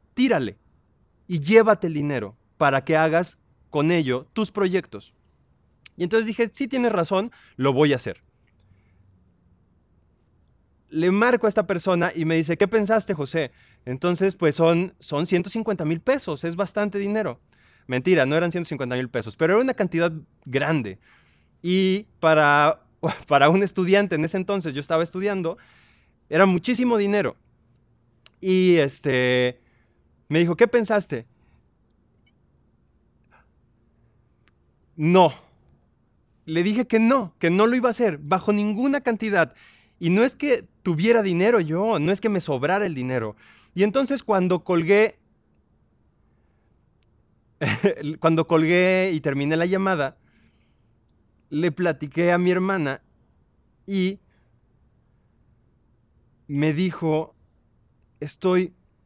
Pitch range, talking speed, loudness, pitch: 135-200 Hz, 125 wpm, -22 LUFS, 170 Hz